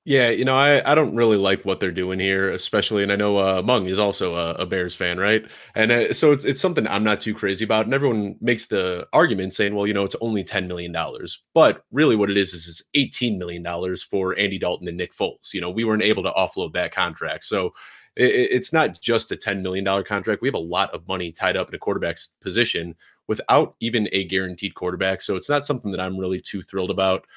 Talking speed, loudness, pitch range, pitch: 240 wpm, -22 LUFS, 95-120 Hz, 100 Hz